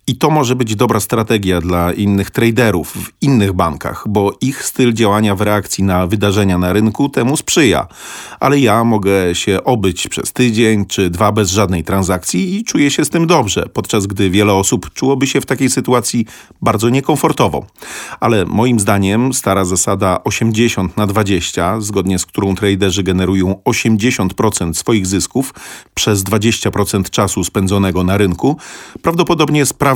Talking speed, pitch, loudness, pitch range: 155 wpm, 105 Hz, -14 LUFS, 95-125 Hz